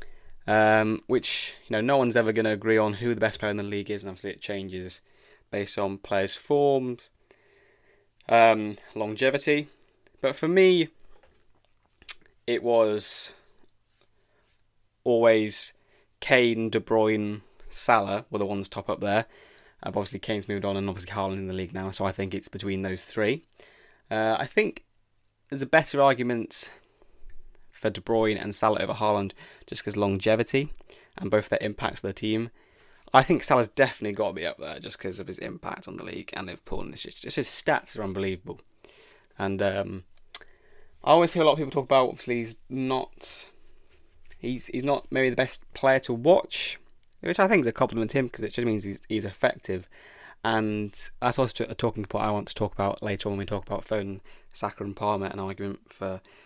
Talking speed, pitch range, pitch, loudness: 190 wpm, 100-120 Hz, 110 Hz, -27 LUFS